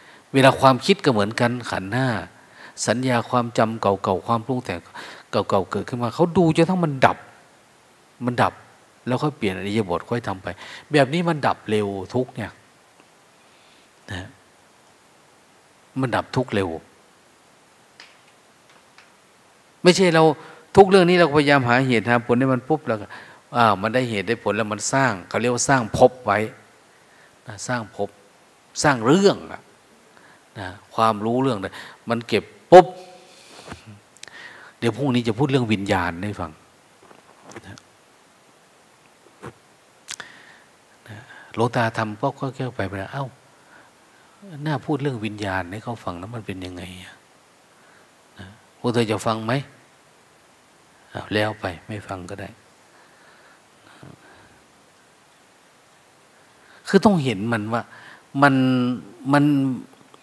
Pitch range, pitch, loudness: 105-135 Hz, 120 Hz, -21 LUFS